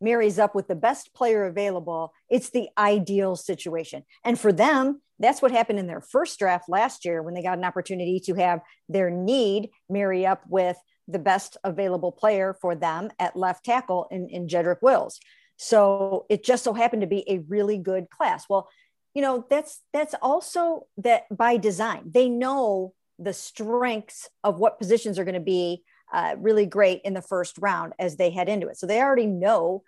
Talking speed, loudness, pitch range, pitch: 190 wpm, -24 LUFS, 185-235 Hz, 200 Hz